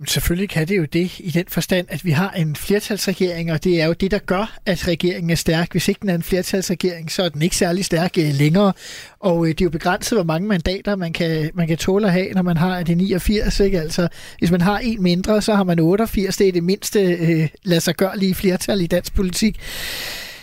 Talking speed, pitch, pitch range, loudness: 235 wpm, 180 Hz, 170-195 Hz, -19 LUFS